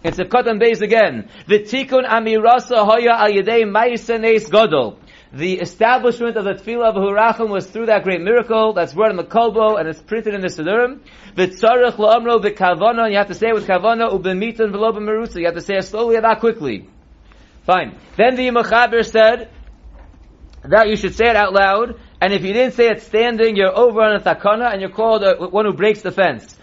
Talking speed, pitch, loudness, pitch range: 215 wpm, 220 Hz, -15 LUFS, 195-230 Hz